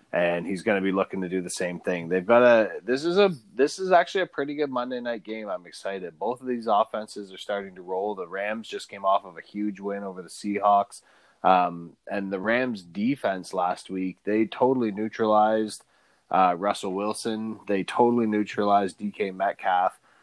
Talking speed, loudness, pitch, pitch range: 195 wpm, -26 LUFS, 105 Hz, 95-120 Hz